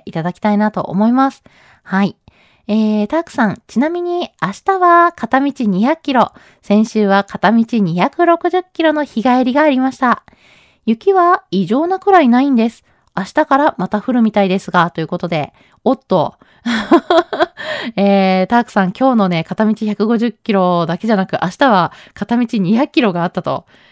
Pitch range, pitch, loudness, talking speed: 195-280 Hz, 225 Hz, -14 LUFS, 295 characters per minute